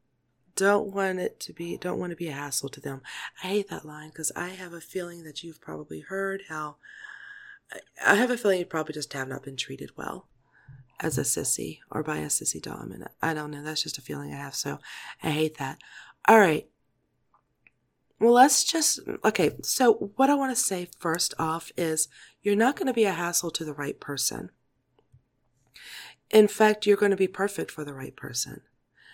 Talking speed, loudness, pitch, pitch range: 200 wpm, -26 LUFS, 170 Hz, 145-205 Hz